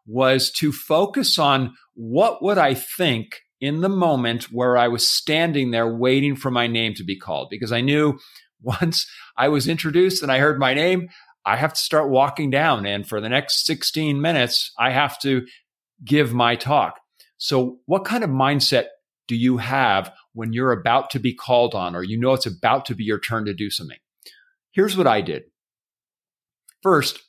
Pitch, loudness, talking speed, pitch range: 130 Hz, -20 LUFS, 185 wpm, 120-155 Hz